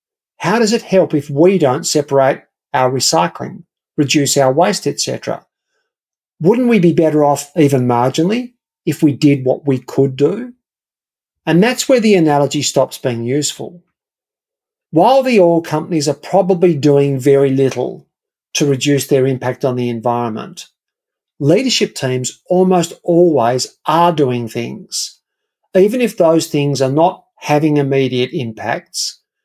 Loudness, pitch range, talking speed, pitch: -14 LUFS, 135-190 Hz, 140 wpm, 150 Hz